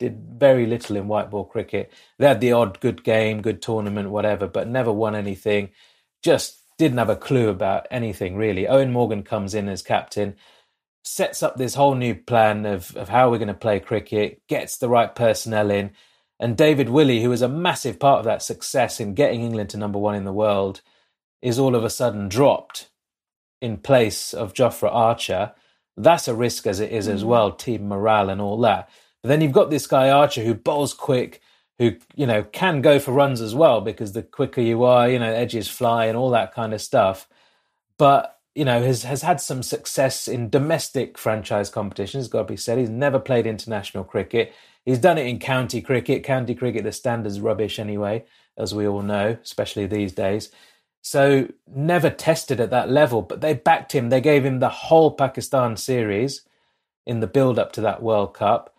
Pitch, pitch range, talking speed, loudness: 115 Hz, 105-135 Hz, 200 wpm, -21 LUFS